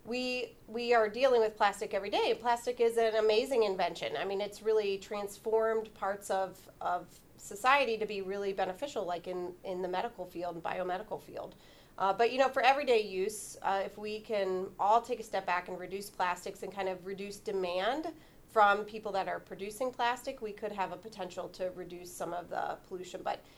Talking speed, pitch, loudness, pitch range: 195 wpm, 205 Hz, -33 LUFS, 185-225 Hz